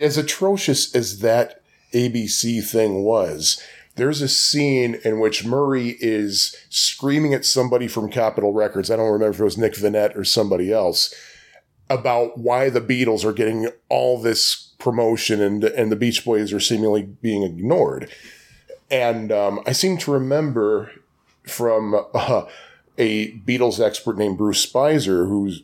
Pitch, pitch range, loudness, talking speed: 115 Hz, 110-130 Hz, -19 LUFS, 150 wpm